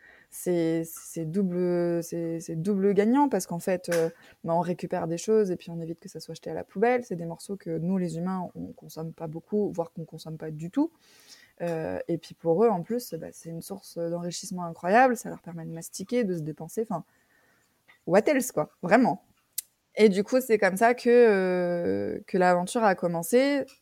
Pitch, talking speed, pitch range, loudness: 175 Hz, 210 wpm, 165-205 Hz, -27 LUFS